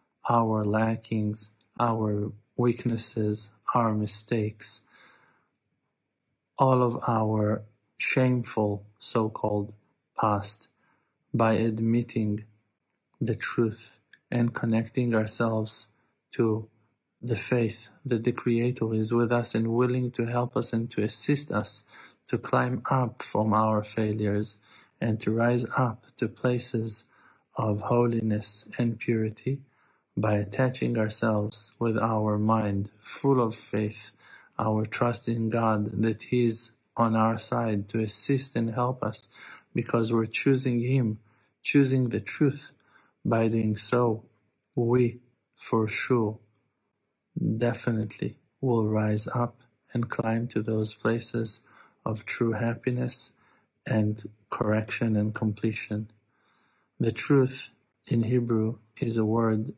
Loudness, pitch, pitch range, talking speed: -28 LUFS, 115 Hz, 110-120 Hz, 115 wpm